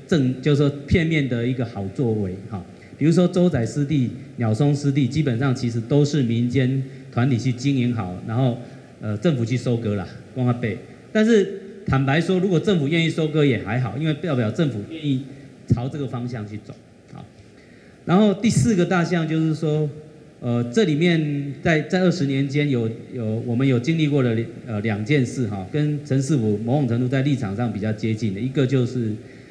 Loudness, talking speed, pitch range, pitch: -22 LUFS, 290 characters per minute, 120-150 Hz, 135 Hz